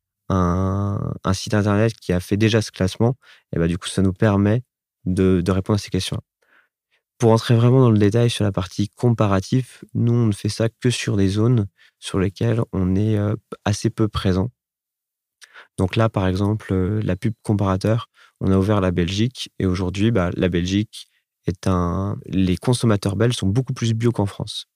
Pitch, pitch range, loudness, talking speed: 105 Hz, 95-115 Hz, -21 LUFS, 185 wpm